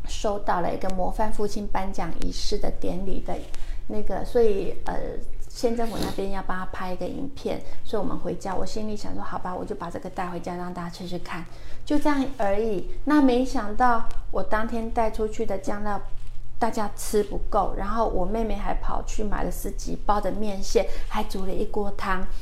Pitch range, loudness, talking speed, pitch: 185-225 Hz, -28 LUFS, 285 characters per minute, 210 Hz